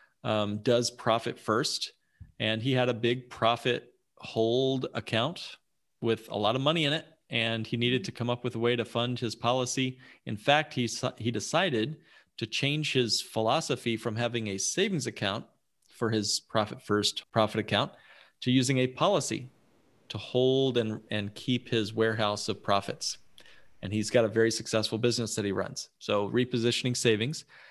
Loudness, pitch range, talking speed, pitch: -29 LUFS, 110-125 Hz, 170 wpm, 120 Hz